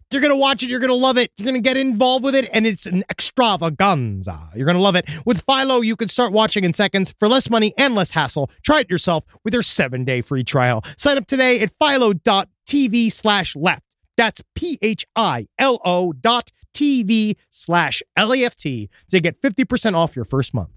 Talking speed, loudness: 210 wpm, -18 LUFS